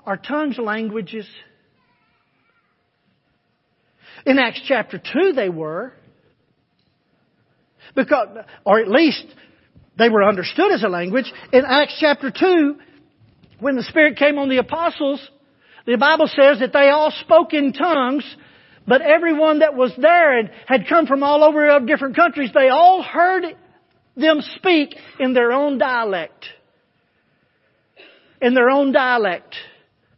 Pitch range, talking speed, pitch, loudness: 255-310 Hz, 130 wpm, 285 Hz, -16 LUFS